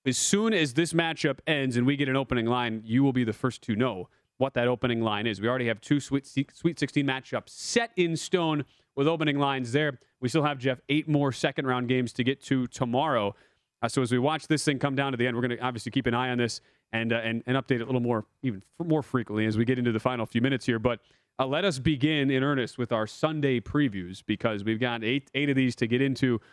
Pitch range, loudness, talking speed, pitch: 120-145 Hz, -27 LUFS, 260 wpm, 130 Hz